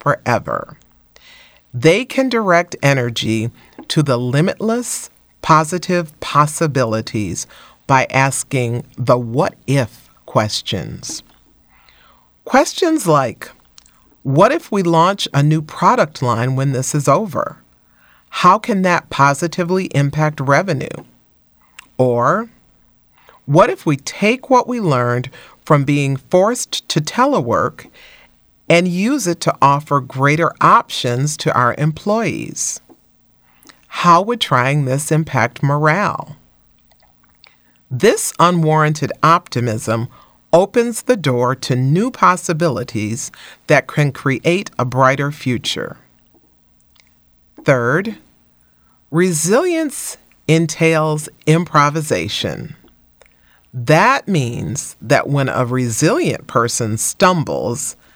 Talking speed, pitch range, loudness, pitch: 95 wpm, 120-170 Hz, -16 LUFS, 145 Hz